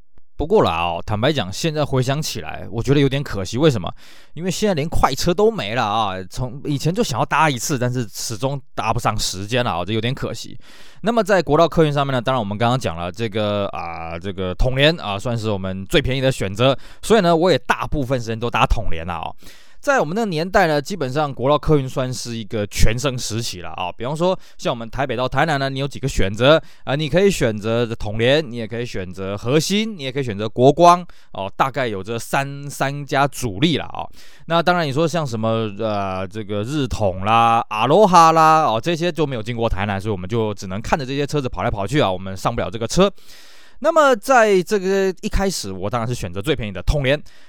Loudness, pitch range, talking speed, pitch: -19 LUFS, 110-155 Hz, 340 characters per minute, 130 Hz